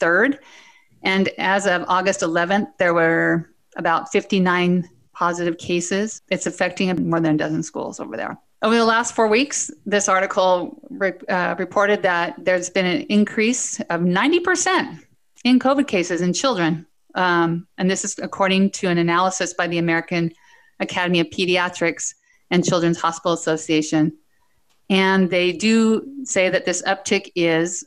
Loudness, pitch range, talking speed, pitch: -20 LUFS, 175-210 Hz, 150 wpm, 185 Hz